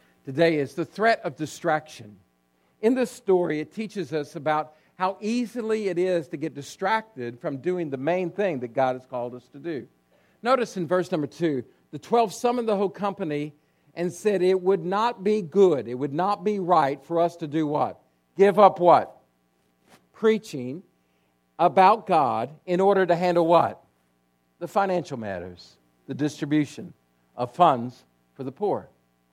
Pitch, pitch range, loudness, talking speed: 160 Hz, 125-190 Hz, -24 LUFS, 165 wpm